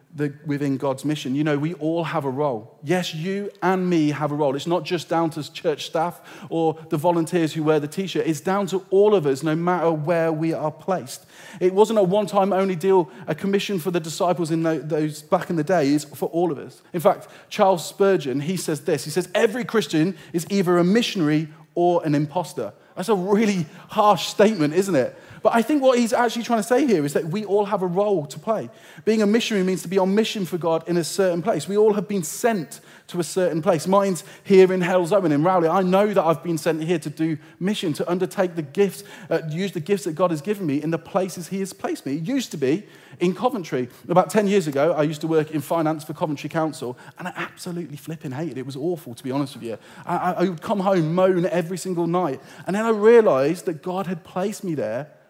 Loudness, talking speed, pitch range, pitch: -22 LUFS, 240 wpm, 155-195 Hz, 175 Hz